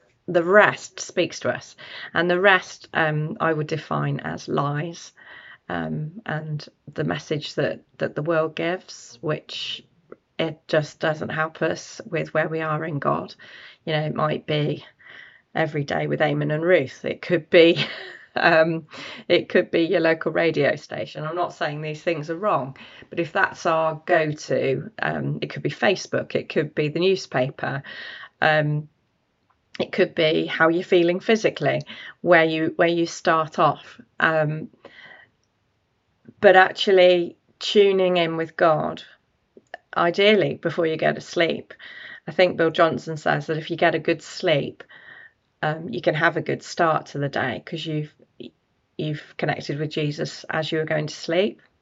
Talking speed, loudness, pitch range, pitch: 160 wpm, -22 LUFS, 150-170 Hz, 160 Hz